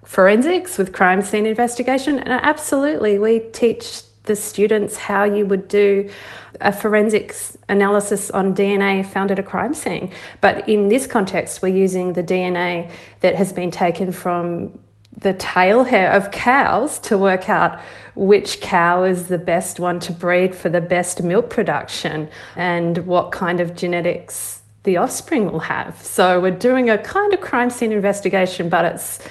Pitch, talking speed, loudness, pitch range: 195 Hz, 160 wpm, -18 LUFS, 180-210 Hz